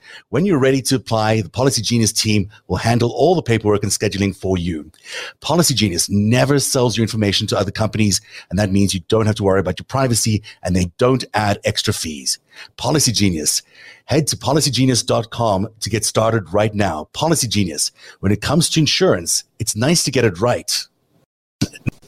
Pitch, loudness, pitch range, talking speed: 110 Hz, -17 LUFS, 100-130 Hz, 180 wpm